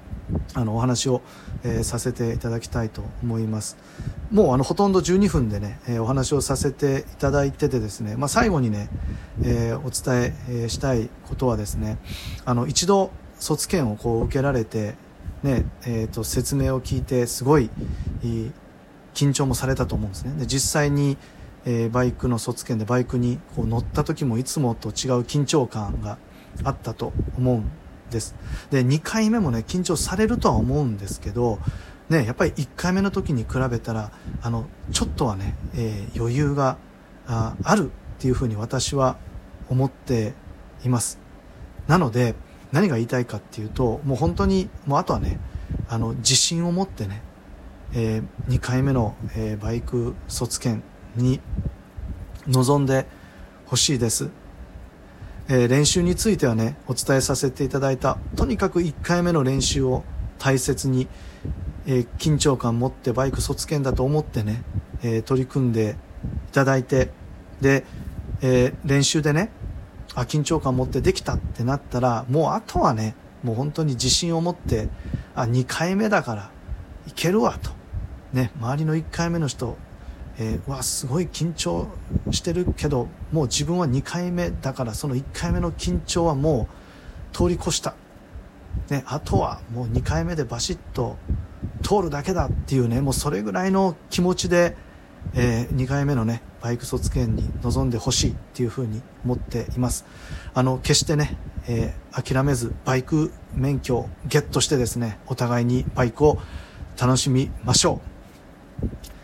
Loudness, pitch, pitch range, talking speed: -23 LUFS, 125 Hz, 110-140 Hz, 290 characters per minute